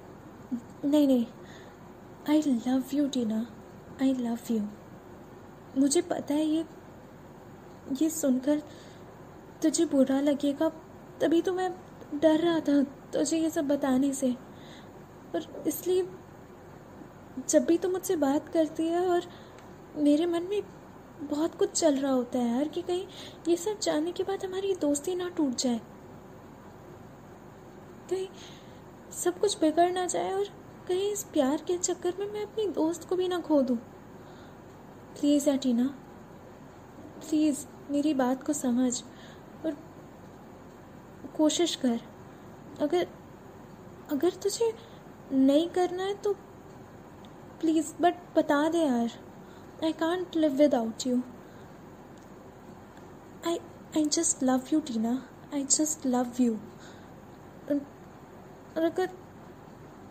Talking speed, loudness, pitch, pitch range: 120 wpm, -29 LUFS, 310 Hz, 275-350 Hz